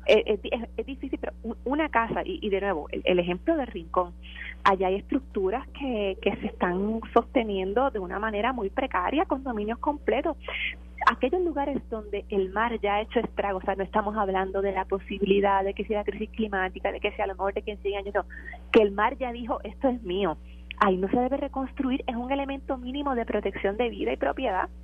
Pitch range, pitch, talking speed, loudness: 195-255 Hz, 215 Hz, 215 wpm, -28 LUFS